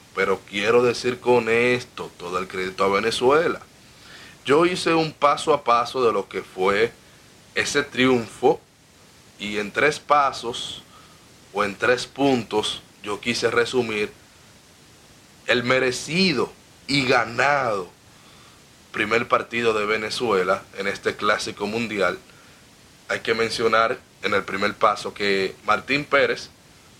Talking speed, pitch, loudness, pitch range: 120 wpm, 120 Hz, -22 LUFS, 105-130 Hz